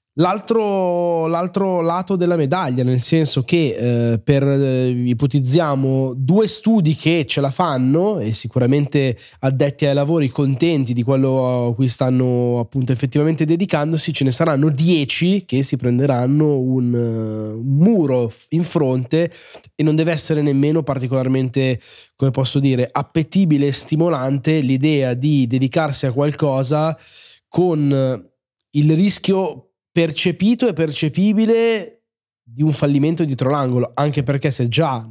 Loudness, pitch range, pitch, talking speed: -17 LUFS, 130-165 Hz, 145 Hz, 130 wpm